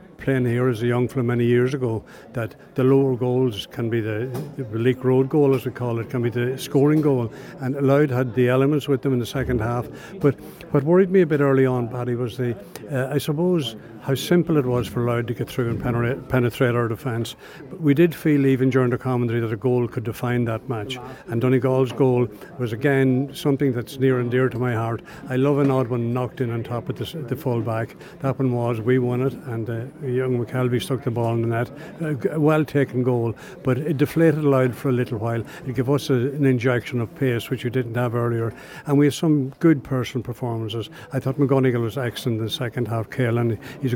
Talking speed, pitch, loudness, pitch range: 230 wpm, 130 Hz, -22 LUFS, 120-135 Hz